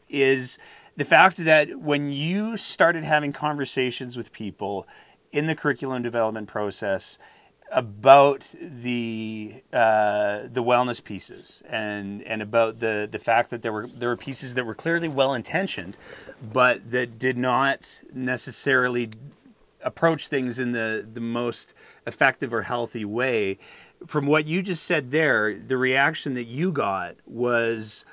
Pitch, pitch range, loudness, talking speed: 125 Hz, 115-145 Hz, -24 LUFS, 140 wpm